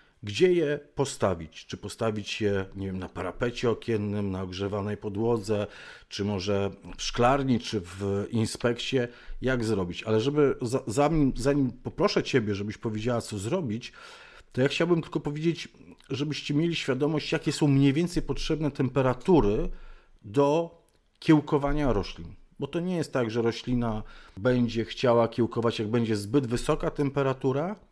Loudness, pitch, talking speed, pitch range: -28 LUFS, 120 Hz, 145 wpm, 105-145 Hz